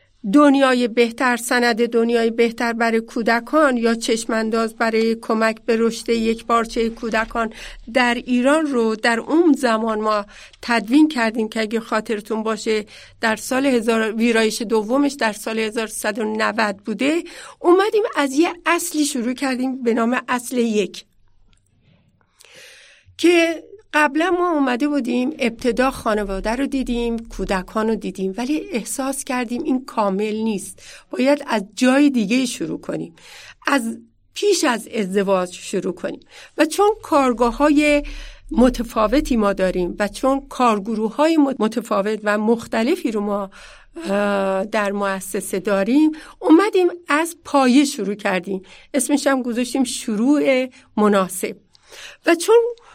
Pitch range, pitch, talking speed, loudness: 220-280 Hz, 235 Hz, 125 wpm, -19 LUFS